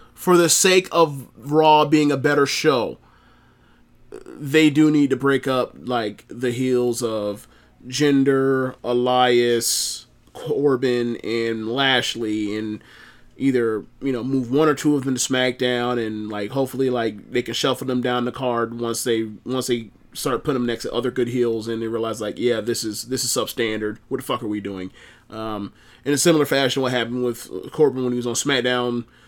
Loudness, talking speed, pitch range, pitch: -21 LUFS, 180 wpm, 115-135 Hz, 125 Hz